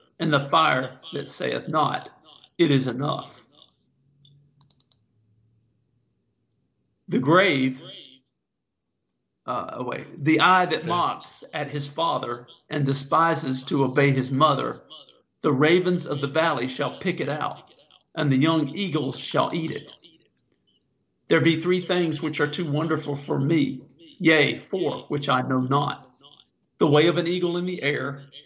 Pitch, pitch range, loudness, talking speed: 145 Hz, 130-160 Hz, -23 LUFS, 140 wpm